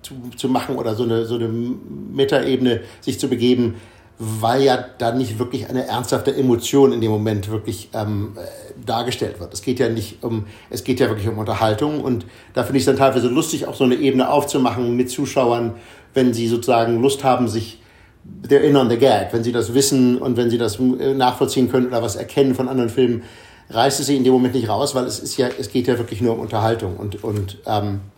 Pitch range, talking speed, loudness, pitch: 115-130 Hz, 215 wpm, -19 LUFS, 120 Hz